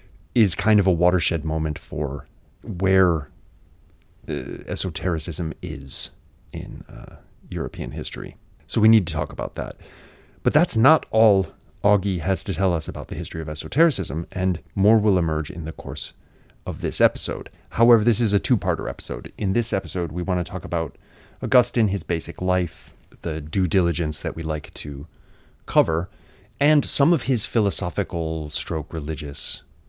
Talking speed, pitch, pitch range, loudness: 160 wpm, 90 Hz, 80-100 Hz, -23 LUFS